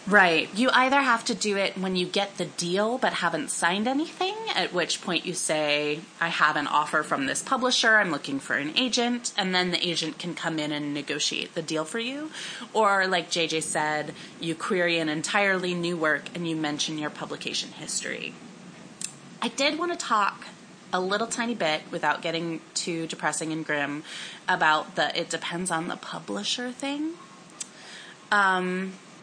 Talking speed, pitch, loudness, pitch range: 175 wpm, 175 Hz, -26 LUFS, 160-215 Hz